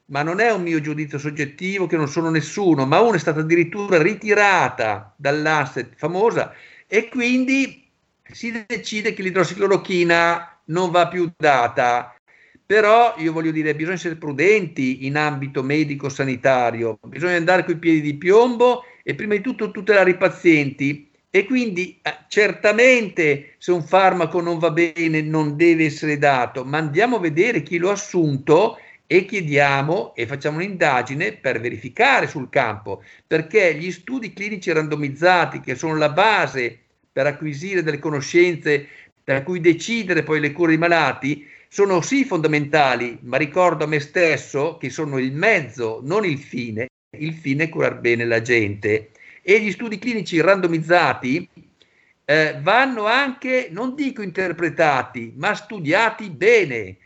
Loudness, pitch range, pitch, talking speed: -19 LUFS, 145-195 Hz, 165 Hz, 145 wpm